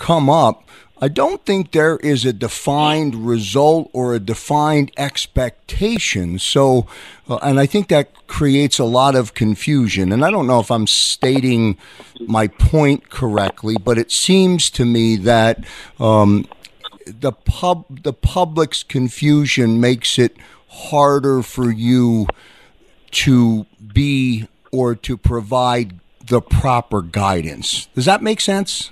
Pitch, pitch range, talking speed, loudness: 125 Hz, 115-145 Hz, 135 wpm, -16 LUFS